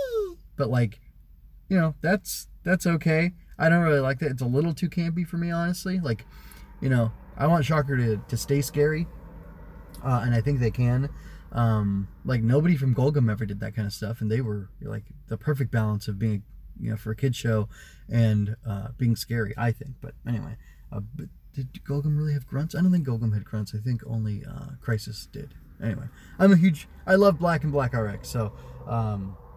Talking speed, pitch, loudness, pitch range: 205 wpm, 125 Hz, -26 LUFS, 110-150 Hz